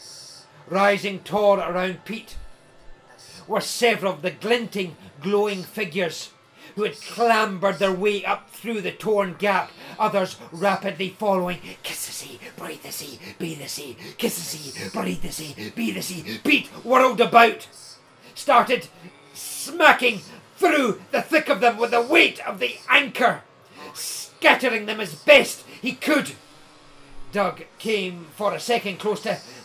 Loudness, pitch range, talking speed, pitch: -22 LUFS, 180-230 Hz, 140 wpm, 200 Hz